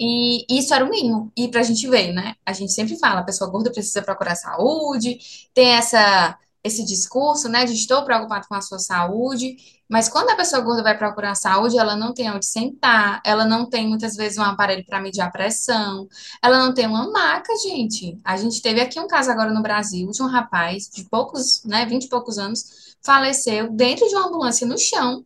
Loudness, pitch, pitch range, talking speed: -19 LUFS, 230 Hz, 205-250 Hz, 220 wpm